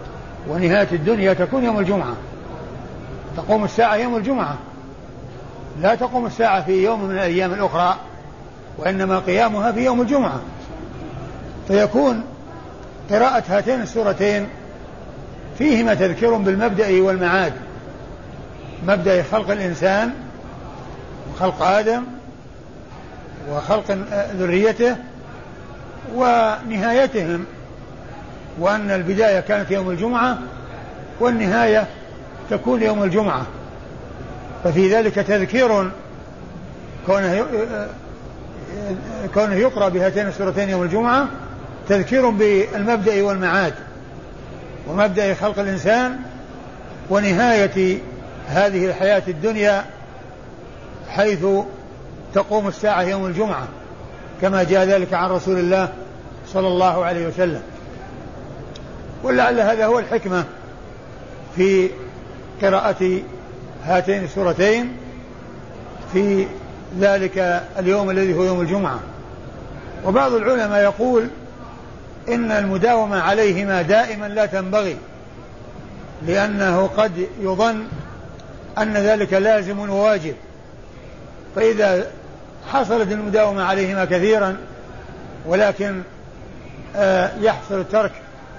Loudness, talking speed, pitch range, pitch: -19 LUFS, 80 wpm, 185-215 Hz, 195 Hz